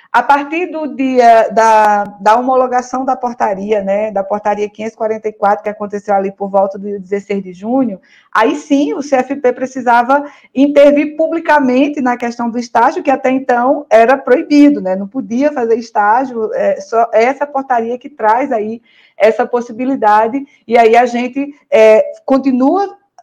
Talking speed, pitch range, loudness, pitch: 150 wpm, 215-275 Hz, -12 LUFS, 245 Hz